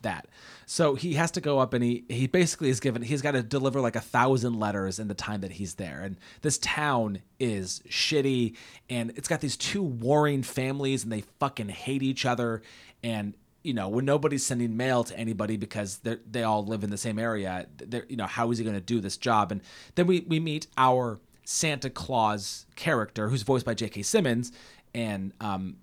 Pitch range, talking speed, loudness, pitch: 105-135 Hz, 210 wpm, -28 LUFS, 120 Hz